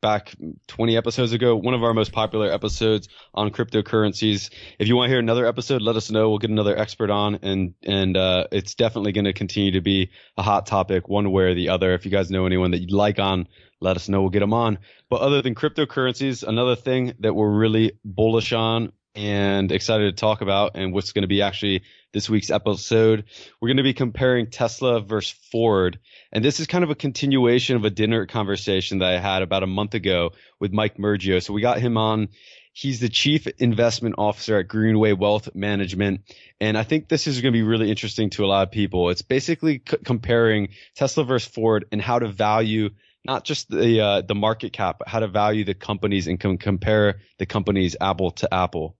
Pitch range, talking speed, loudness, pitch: 100-115 Hz, 215 wpm, -22 LUFS, 105 Hz